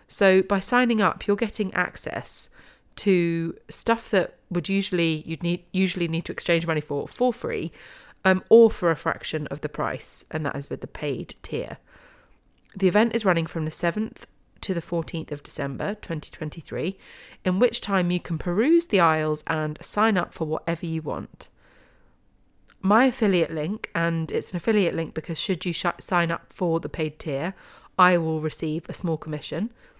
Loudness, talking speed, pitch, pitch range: -25 LUFS, 180 wpm, 175 Hz, 160-200 Hz